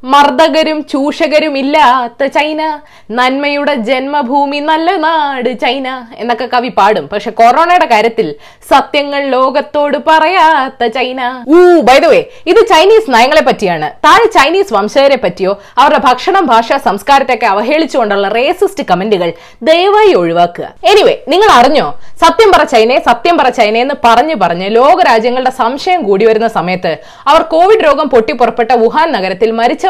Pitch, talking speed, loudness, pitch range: 275 Hz, 125 wpm, -9 LUFS, 230-315 Hz